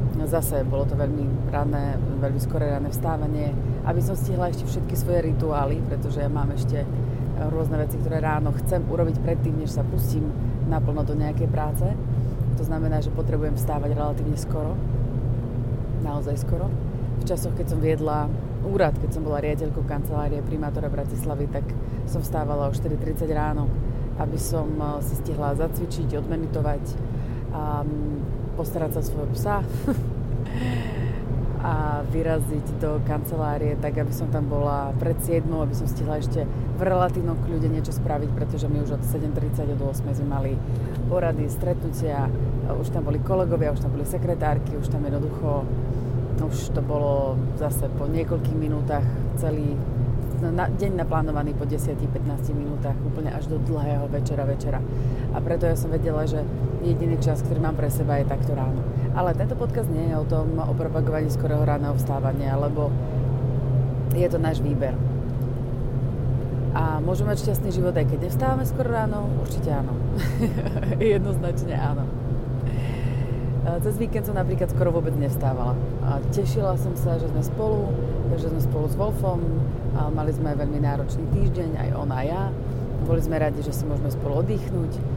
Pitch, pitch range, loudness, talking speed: 130 Hz, 125-145 Hz, -25 LUFS, 155 wpm